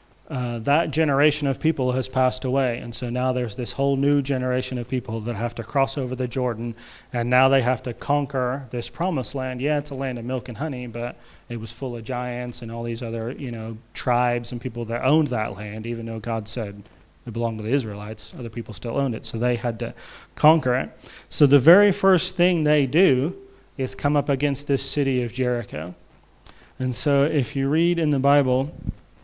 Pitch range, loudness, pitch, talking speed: 120-140 Hz, -23 LUFS, 125 Hz, 220 wpm